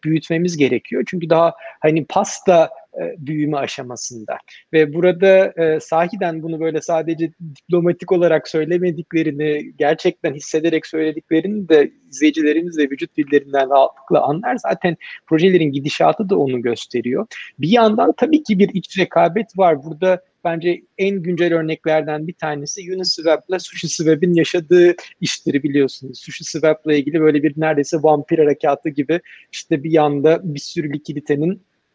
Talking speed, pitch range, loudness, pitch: 130 wpm, 150-180 Hz, -17 LUFS, 165 Hz